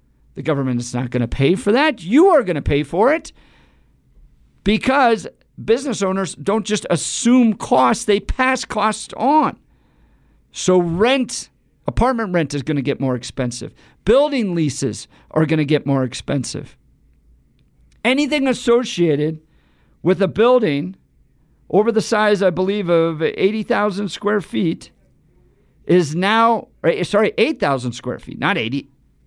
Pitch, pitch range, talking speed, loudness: 190 Hz, 145-225 Hz, 135 wpm, -18 LUFS